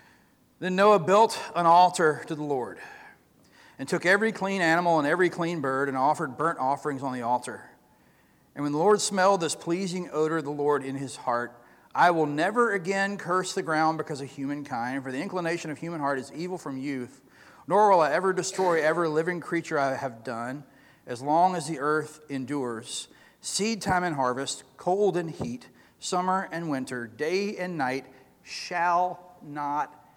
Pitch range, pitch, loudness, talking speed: 135-180 Hz, 155 Hz, -26 LUFS, 180 wpm